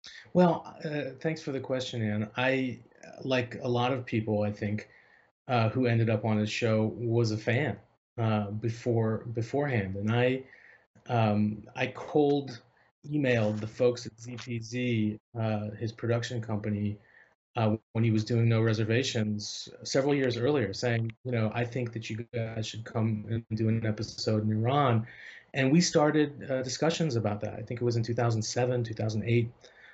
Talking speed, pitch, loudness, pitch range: 165 wpm, 115 Hz, -30 LUFS, 110-125 Hz